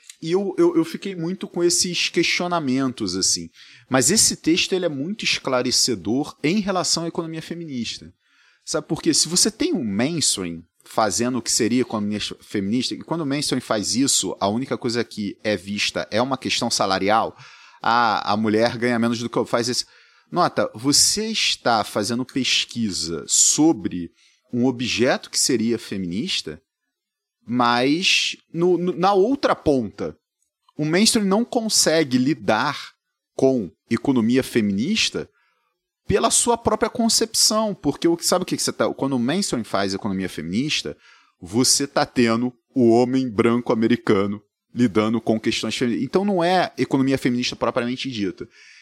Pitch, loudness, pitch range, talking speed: 135 Hz, -20 LUFS, 115-180 Hz, 150 wpm